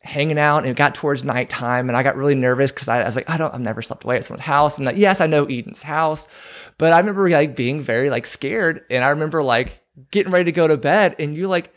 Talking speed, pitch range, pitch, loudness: 270 wpm, 130-160 Hz, 145 Hz, -18 LUFS